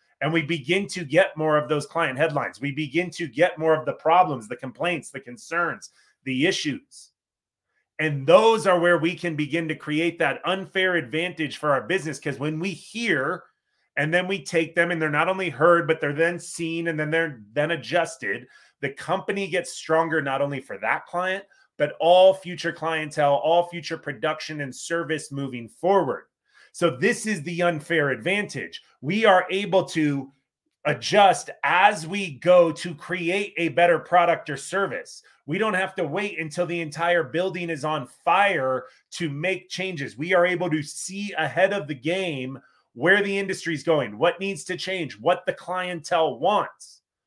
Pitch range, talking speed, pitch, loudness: 155-185 Hz, 180 wpm, 170 Hz, -23 LUFS